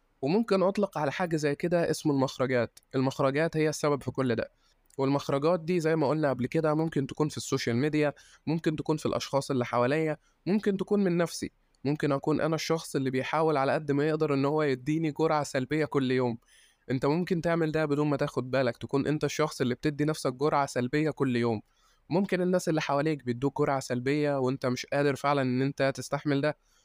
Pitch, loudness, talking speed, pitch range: 145 Hz, -29 LUFS, 190 wpm, 135-155 Hz